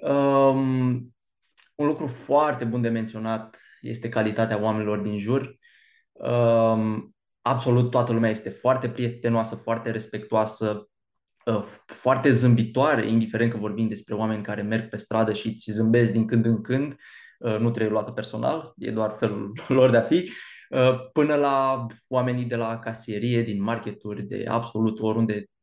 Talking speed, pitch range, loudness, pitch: 150 wpm, 110-125 Hz, -24 LUFS, 115 Hz